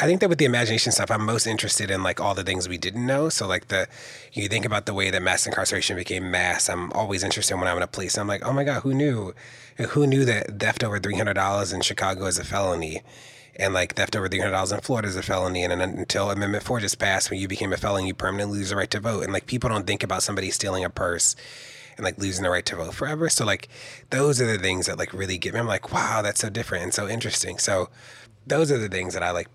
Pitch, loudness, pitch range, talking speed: 100 Hz, -24 LUFS, 95-120 Hz, 270 wpm